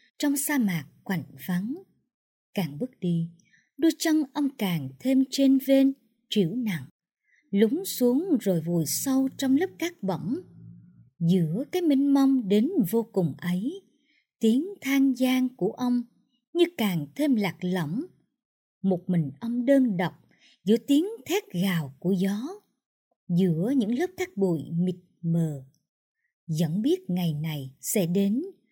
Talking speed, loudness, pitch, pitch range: 140 wpm, -26 LUFS, 225 Hz, 175-275 Hz